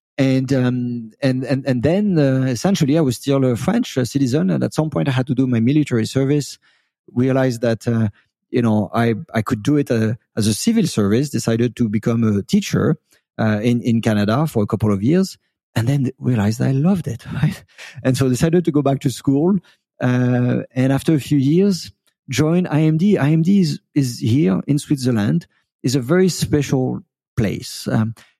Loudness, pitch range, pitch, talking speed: -18 LUFS, 115-150 Hz, 130 Hz, 190 wpm